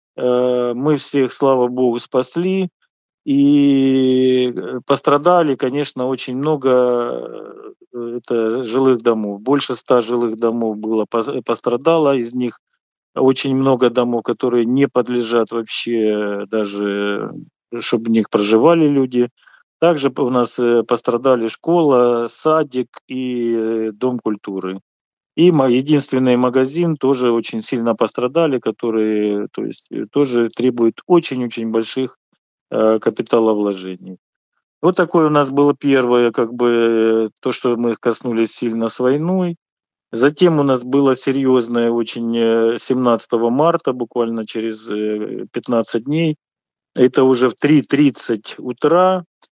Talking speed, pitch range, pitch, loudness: 110 wpm, 115-140 Hz, 125 Hz, -17 LUFS